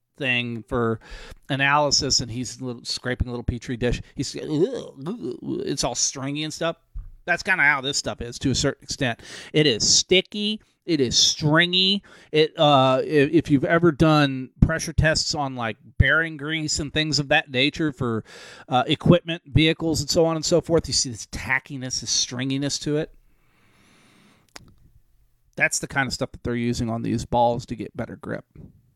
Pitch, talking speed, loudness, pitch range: 140 Hz, 175 wpm, -22 LUFS, 120-155 Hz